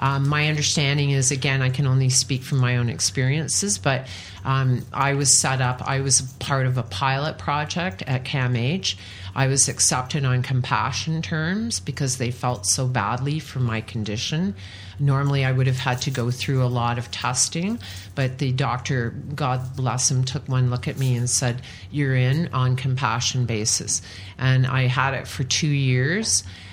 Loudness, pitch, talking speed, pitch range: -22 LUFS, 130 Hz, 175 wpm, 120-140 Hz